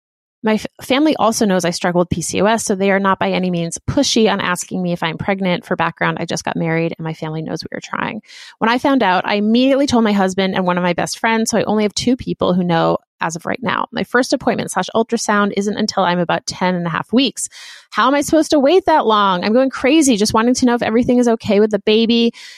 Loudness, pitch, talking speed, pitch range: -16 LUFS, 210 Hz, 260 wpm, 180-245 Hz